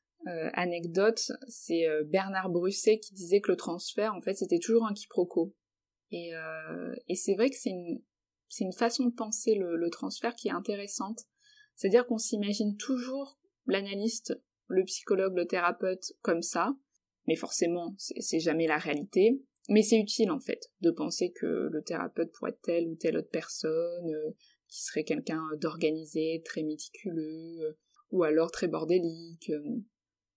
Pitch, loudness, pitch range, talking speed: 185 Hz, -31 LUFS, 165-225 Hz, 165 wpm